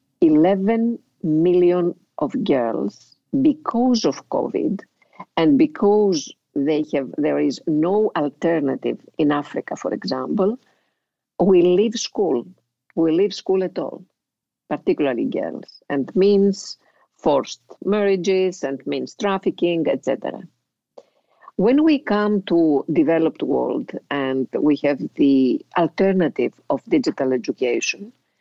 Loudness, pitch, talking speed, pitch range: -20 LUFS, 180 Hz, 110 wpm, 150-205 Hz